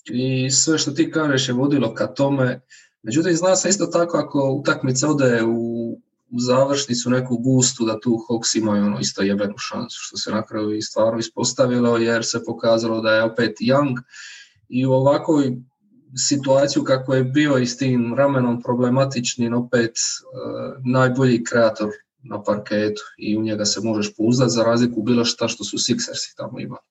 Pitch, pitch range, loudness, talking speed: 125 Hz, 115-135 Hz, -20 LUFS, 170 wpm